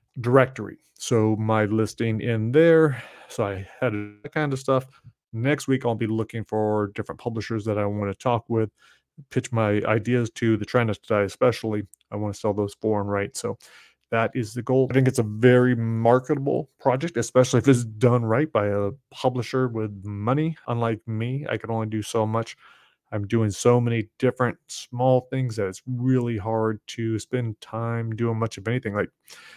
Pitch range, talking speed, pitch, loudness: 110-125 Hz, 185 wpm, 115 Hz, -24 LUFS